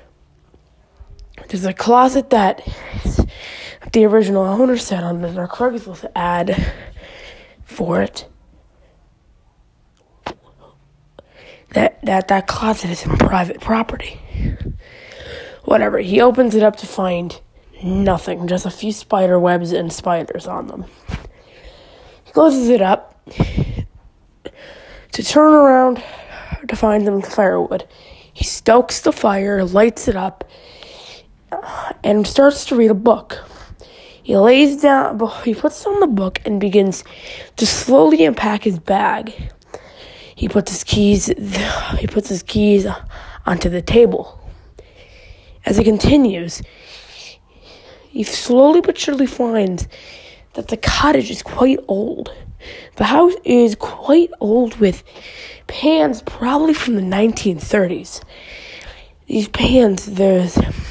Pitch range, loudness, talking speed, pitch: 190-285 Hz, -16 LUFS, 115 wpm, 220 Hz